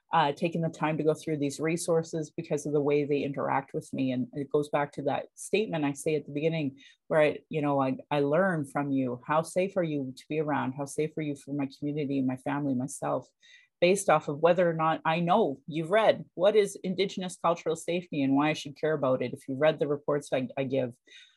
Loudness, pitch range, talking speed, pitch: -29 LUFS, 140-165 Hz, 240 wpm, 150 Hz